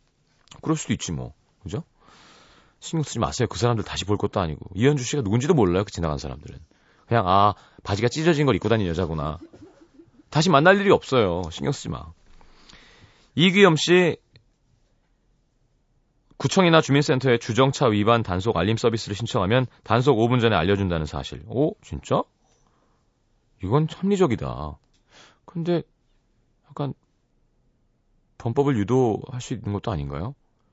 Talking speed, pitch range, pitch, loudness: 295 characters per minute, 100-145 Hz, 120 Hz, -22 LUFS